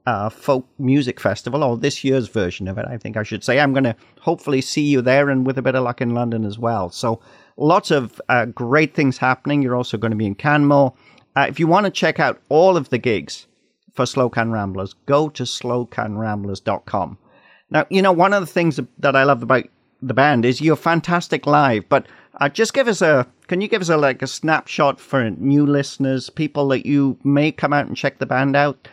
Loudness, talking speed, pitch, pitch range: -18 LUFS, 225 wpm, 135 Hz, 120-145 Hz